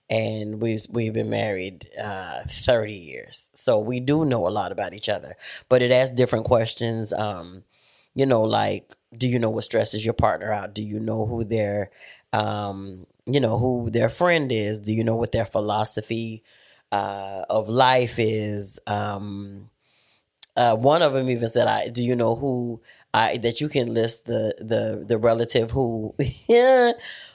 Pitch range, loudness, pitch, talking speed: 105-125 Hz, -23 LUFS, 115 Hz, 170 wpm